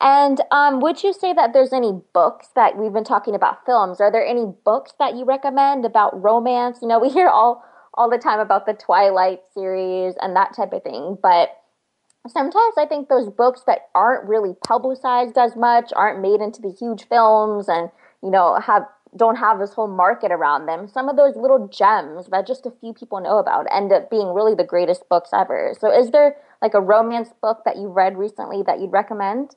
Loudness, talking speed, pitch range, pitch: -18 LUFS, 210 wpm, 195-260 Hz, 220 Hz